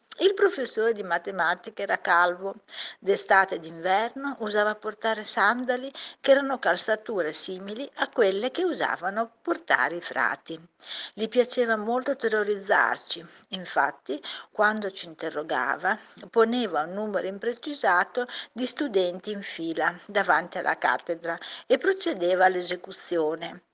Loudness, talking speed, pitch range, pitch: -26 LUFS, 115 wpm, 180-250 Hz, 210 Hz